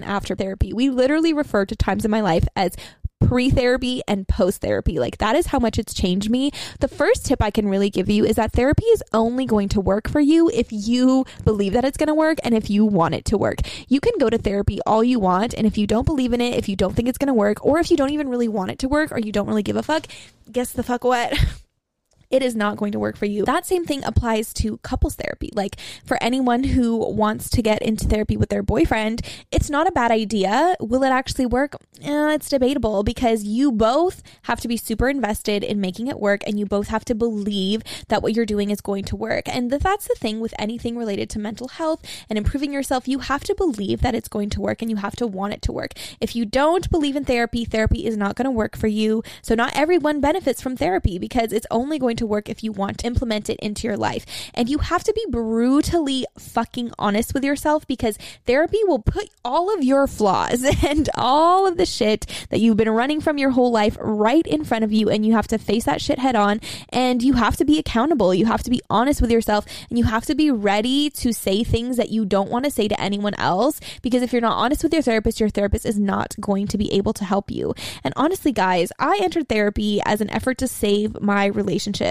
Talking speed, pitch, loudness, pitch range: 250 wpm, 235 Hz, -21 LUFS, 210-275 Hz